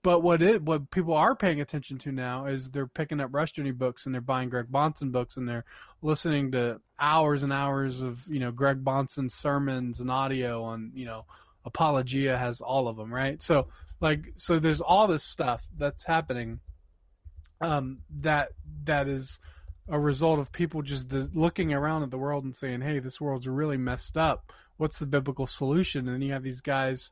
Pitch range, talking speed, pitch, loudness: 125-150 Hz, 195 wpm, 135 Hz, -29 LUFS